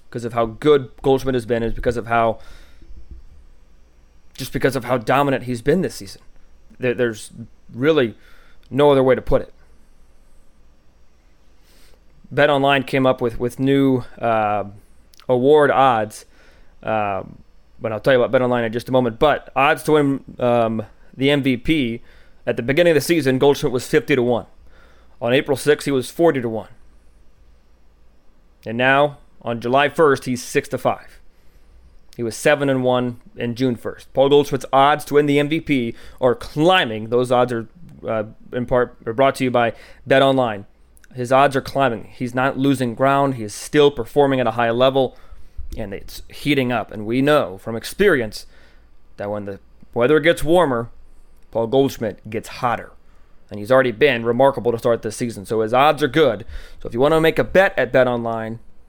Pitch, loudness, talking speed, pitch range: 120 Hz, -19 LUFS, 175 wpm, 105-135 Hz